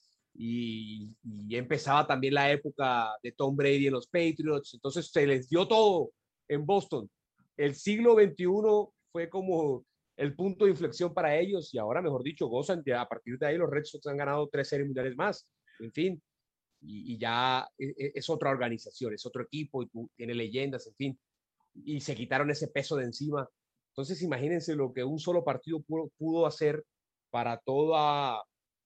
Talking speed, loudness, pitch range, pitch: 180 wpm, -31 LUFS, 130-160 Hz, 145 Hz